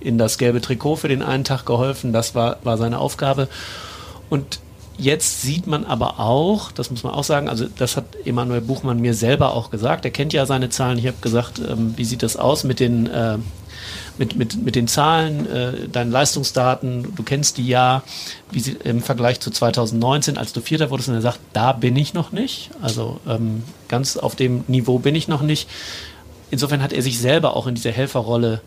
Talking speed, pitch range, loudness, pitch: 205 wpm, 115-140 Hz, -20 LUFS, 125 Hz